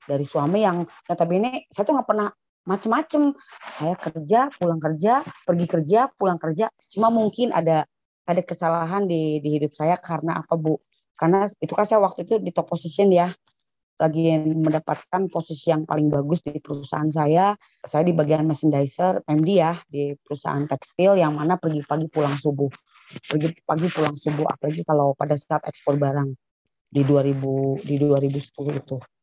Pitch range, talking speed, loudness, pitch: 150-185 Hz, 165 wpm, -22 LUFS, 160 Hz